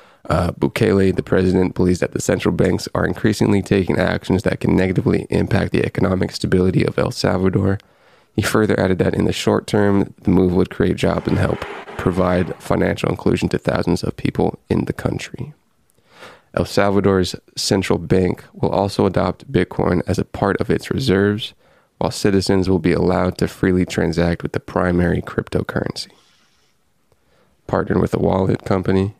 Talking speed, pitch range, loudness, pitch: 160 wpm, 90-100 Hz, -18 LUFS, 95 Hz